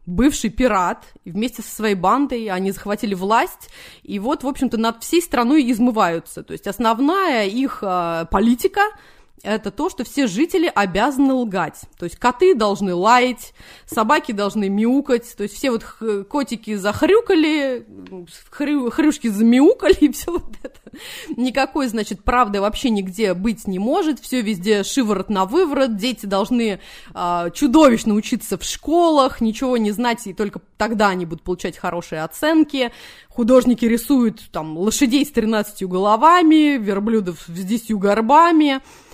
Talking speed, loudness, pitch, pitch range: 145 wpm, -18 LUFS, 230 Hz, 205-280 Hz